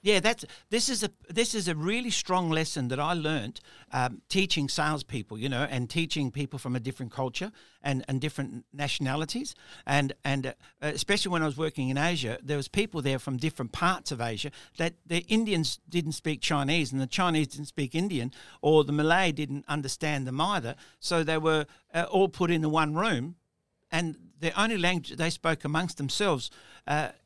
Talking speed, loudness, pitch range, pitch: 190 wpm, -29 LUFS, 140-175 Hz, 155 Hz